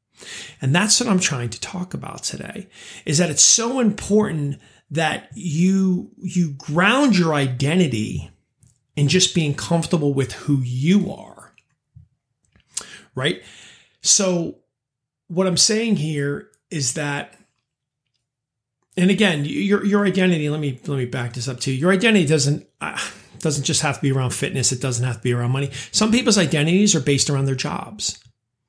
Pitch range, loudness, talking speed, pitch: 135-185 Hz, -19 LUFS, 155 wpm, 150 Hz